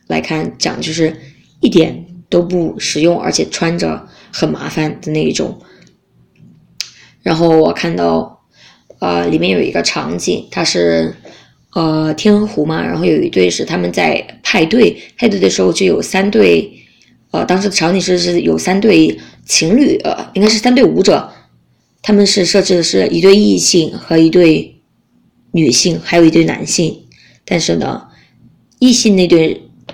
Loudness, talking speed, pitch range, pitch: -12 LUFS, 225 characters per minute, 150-190 Hz, 165 Hz